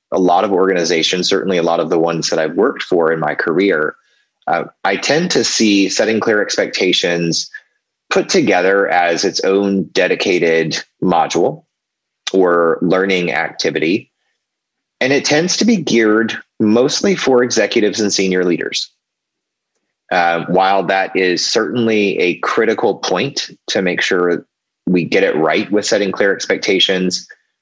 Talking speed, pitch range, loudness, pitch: 145 wpm, 90-110 Hz, -15 LUFS, 95 Hz